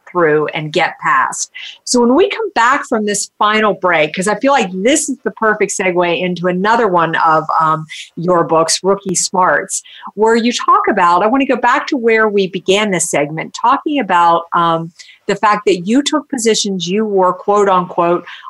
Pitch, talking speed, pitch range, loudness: 200 Hz, 190 wpm, 175-230 Hz, -13 LUFS